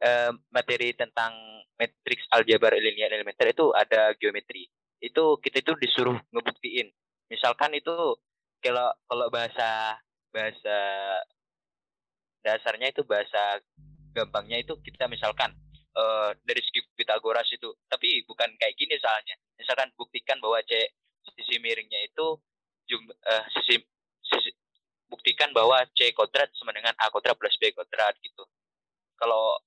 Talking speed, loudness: 125 wpm, -26 LUFS